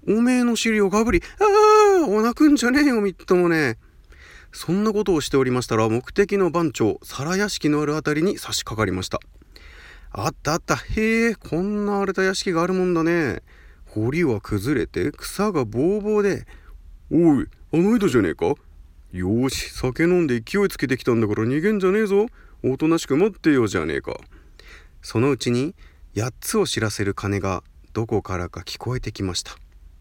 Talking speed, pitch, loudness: 345 characters per minute, 155 Hz, -21 LUFS